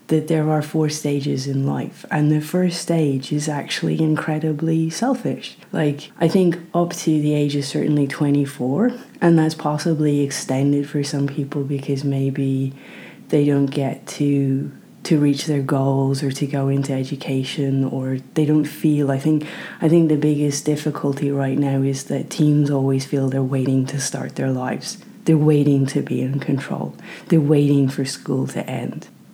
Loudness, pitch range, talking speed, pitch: -20 LUFS, 135-155 Hz, 170 wpm, 145 Hz